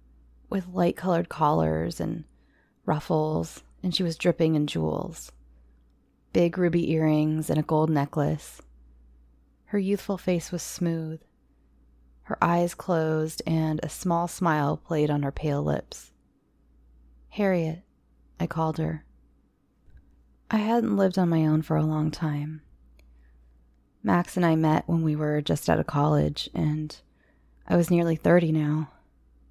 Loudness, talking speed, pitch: -26 LUFS, 135 wpm, 150 Hz